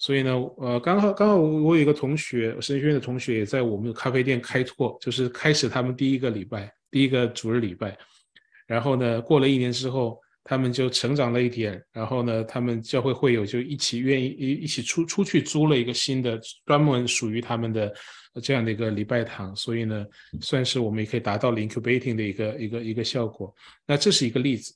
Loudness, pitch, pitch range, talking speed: -24 LUFS, 125 Hz, 115-135 Hz, 355 characters per minute